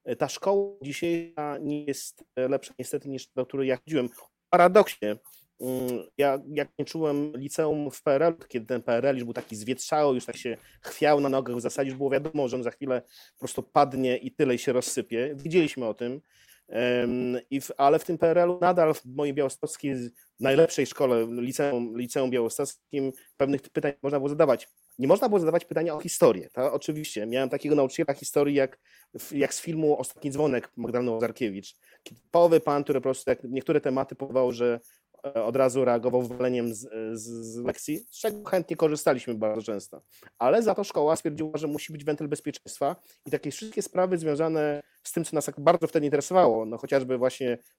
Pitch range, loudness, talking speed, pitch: 125-155 Hz, -27 LUFS, 185 wpm, 140 Hz